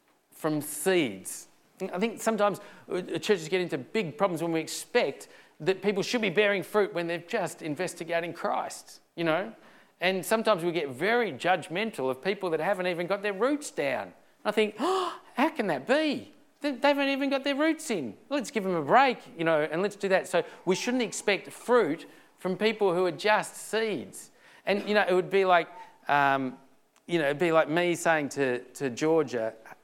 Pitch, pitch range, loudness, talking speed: 195 Hz, 170-225 Hz, -28 LUFS, 190 wpm